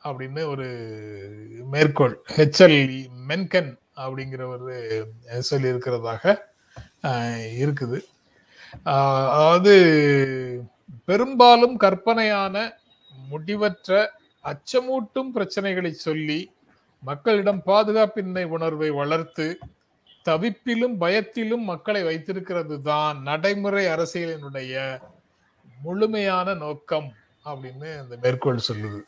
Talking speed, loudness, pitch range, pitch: 70 wpm, -22 LUFS, 130-200 Hz, 155 Hz